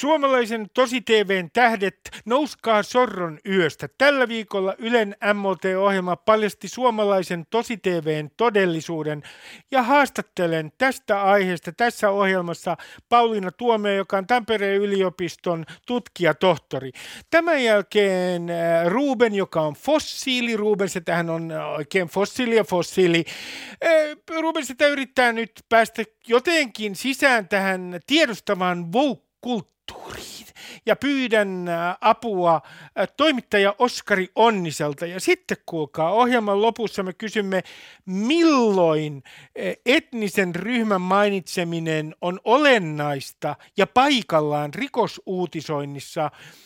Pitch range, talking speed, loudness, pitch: 175-240 Hz, 100 wpm, -22 LUFS, 200 Hz